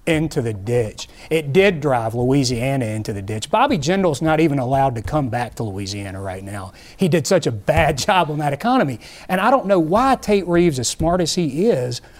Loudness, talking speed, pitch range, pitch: -19 LUFS, 210 wpm, 115-180 Hz, 150 Hz